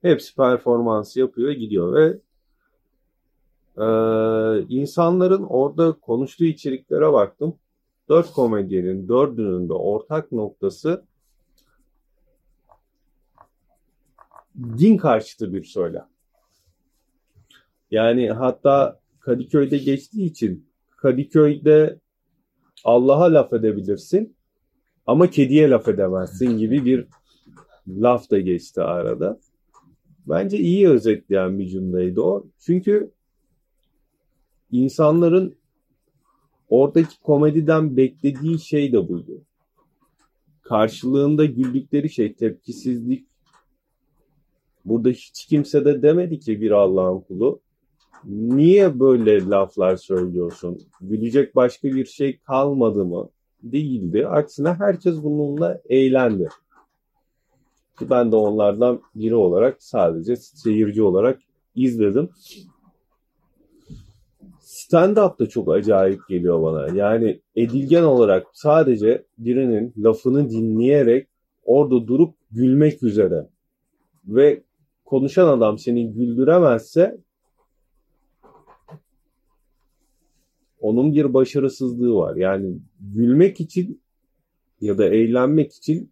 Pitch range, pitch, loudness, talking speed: 110-155 Hz, 130 Hz, -19 LUFS, 85 wpm